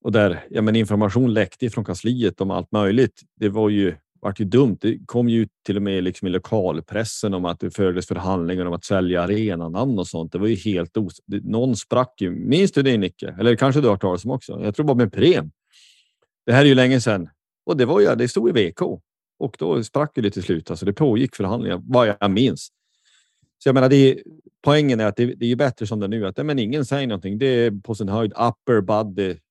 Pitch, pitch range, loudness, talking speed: 110 Hz, 95-120 Hz, -20 LUFS, 235 wpm